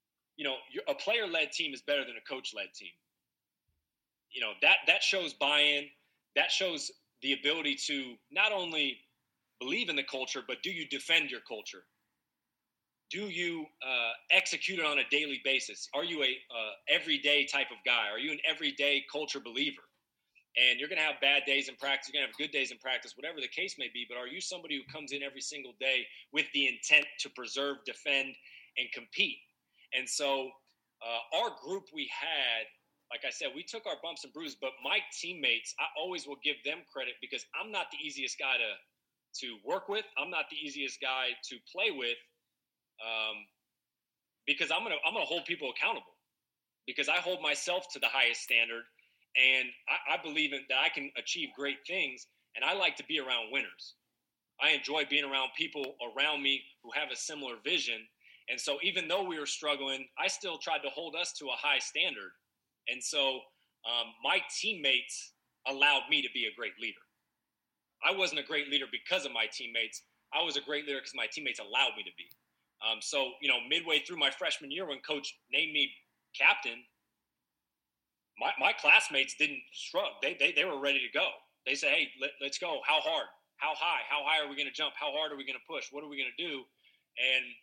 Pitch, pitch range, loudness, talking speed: 140 Hz, 130-155 Hz, -31 LUFS, 200 wpm